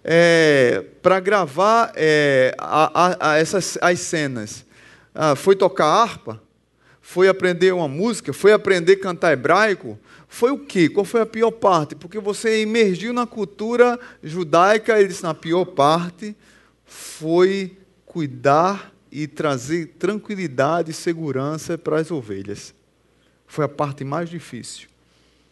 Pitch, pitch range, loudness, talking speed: 170 Hz, 150-195 Hz, -19 LUFS, 130 wpm